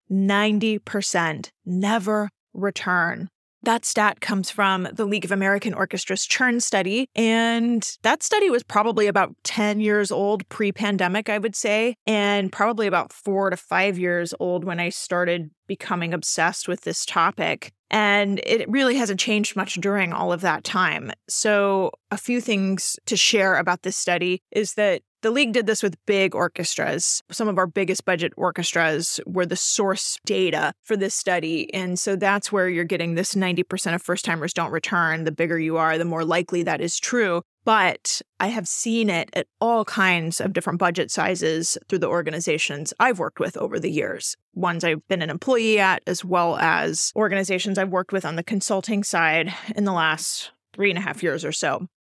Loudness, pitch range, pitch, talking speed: -22 LUFS, 175-210 Hz, 195 Hz, 180 wpm